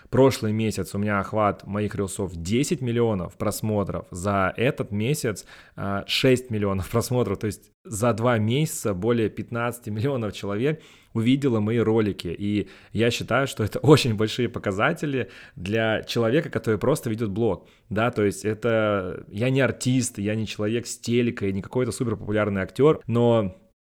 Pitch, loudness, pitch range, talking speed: 110 Hz, -24 LUFS, 105-120 Hz, 150 wpm